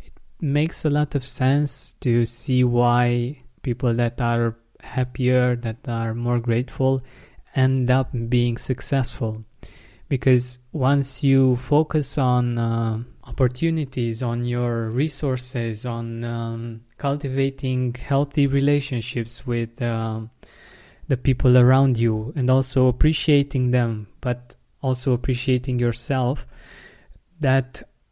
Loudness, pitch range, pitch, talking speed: -22 LUFS, 120-135 Hz, 125 Hz, 105 wpm